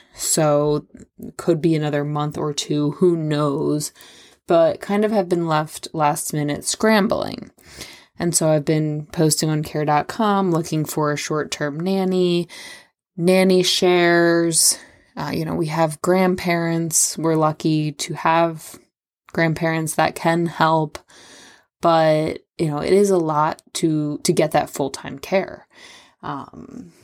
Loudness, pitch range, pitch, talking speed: -19 LUFS, 155-180 Hz, 165 Hz, 140 wpm